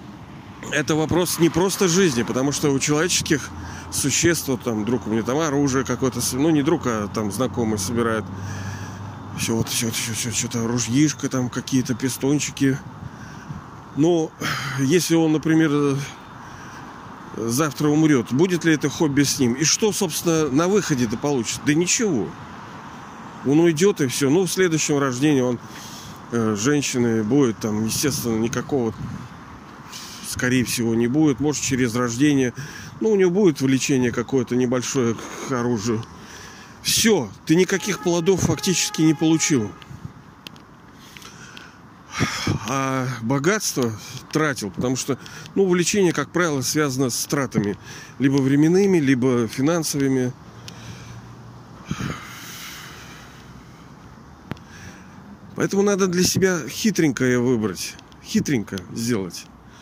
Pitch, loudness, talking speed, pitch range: 140 Hz, -21 LUFS, 115 wpm, 120-160 Hz